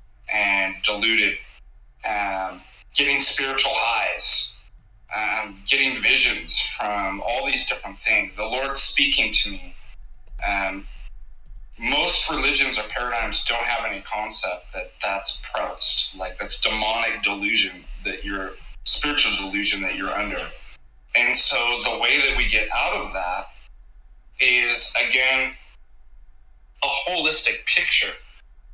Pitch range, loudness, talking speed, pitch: 95-130 Hz, -21 LUFS, 120 wpm, 105 Hz